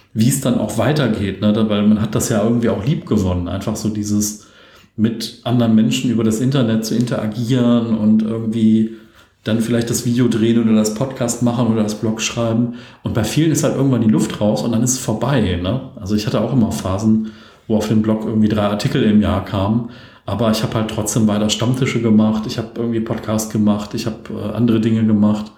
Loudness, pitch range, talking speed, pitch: -17 LUFS, 110-120 Hz, 210 wpm, 110 Hz